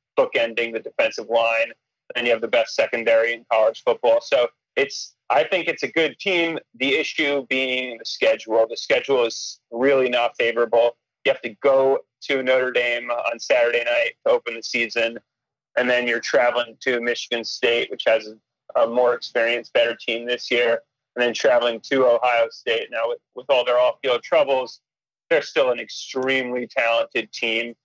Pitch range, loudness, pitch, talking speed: 115-150 Hz, -21 LUFS, 125 Hz, 180 wpm